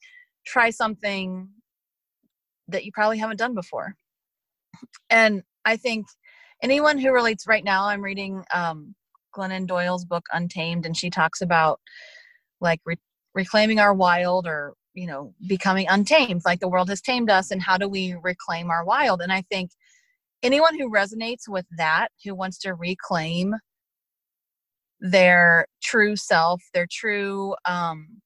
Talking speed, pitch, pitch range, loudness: 145 wpm, 195 Hz, 180-225 Hz, -22 LUFS